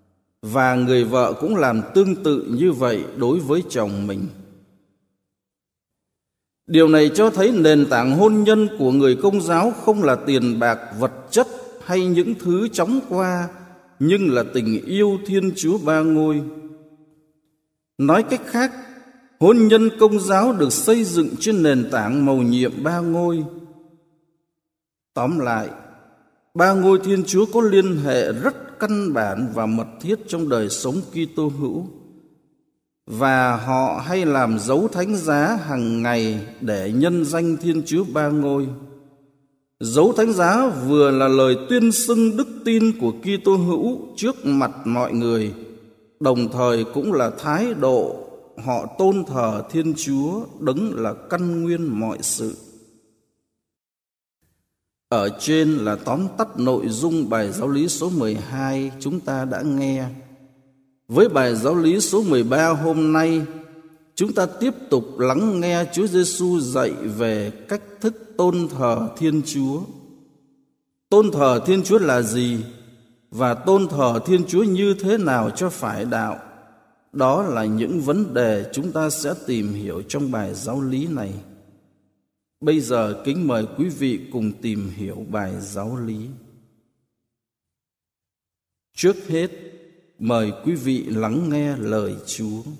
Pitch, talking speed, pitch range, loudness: 150 Hz, 145 wpm, 120-185 Hz, -20 LUFS